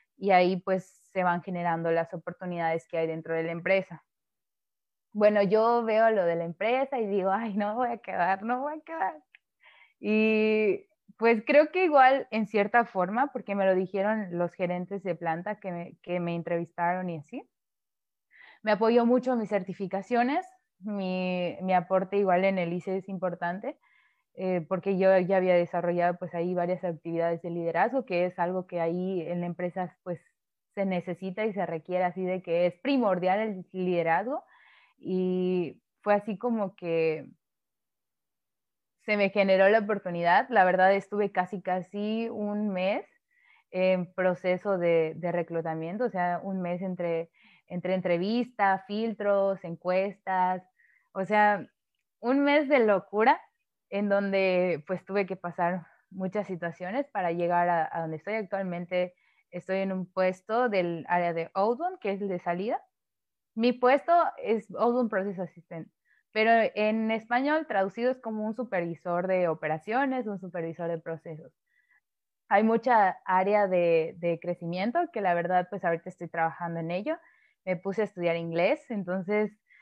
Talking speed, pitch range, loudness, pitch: 155 wpm, 175-215 Hz, -28 LUFS, 190 Hz